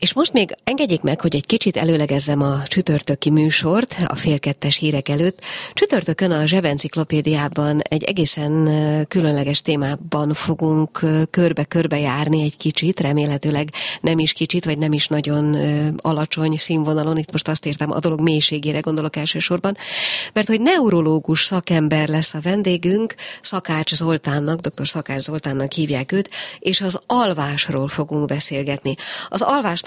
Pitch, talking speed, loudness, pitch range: 155 Hz, 135 wpm, -18 LUFS, 150-170 Hz